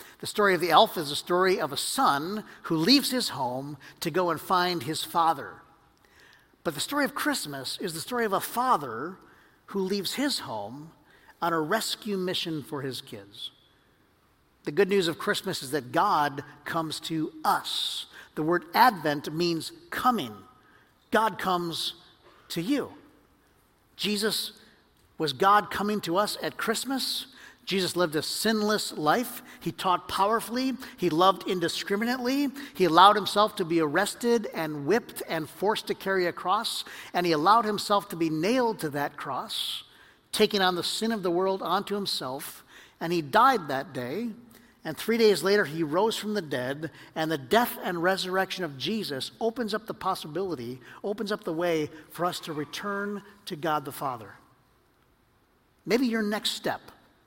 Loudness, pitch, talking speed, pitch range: -27 LUFS, 190 Hz, 165 wpm, 160-215 Hz